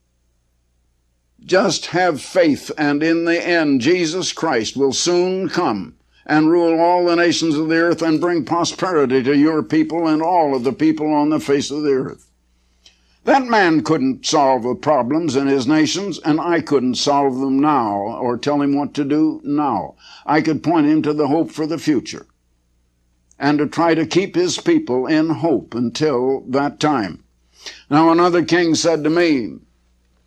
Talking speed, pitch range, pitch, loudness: 170 wpm, 125-170 Hz, 150 Hz, -17 LUFS